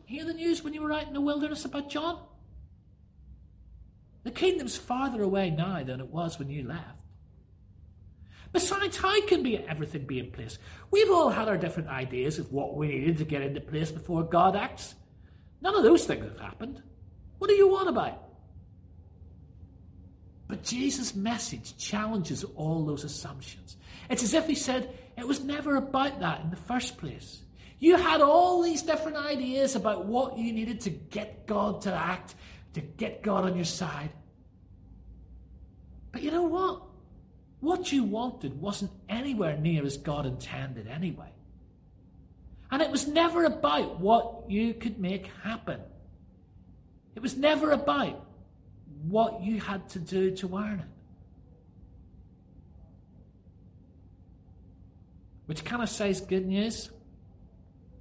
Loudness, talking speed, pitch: -29 LUFS, 150 wpm, 170 Hz